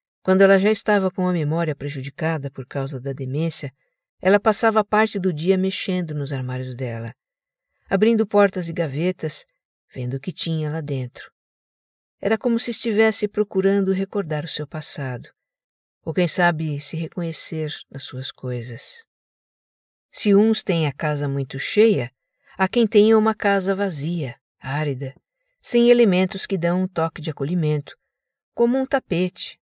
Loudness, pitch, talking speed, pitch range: -21 LUFS, 175 Hz, 150 wpm, 145-205 Hz